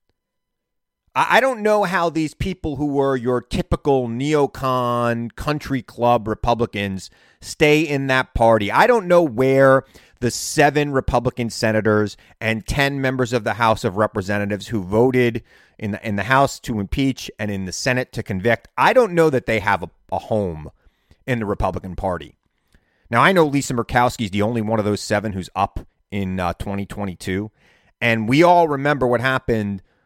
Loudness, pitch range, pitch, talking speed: -19 LUFS, 105-135 Hz, 120 Hz, 170 wpm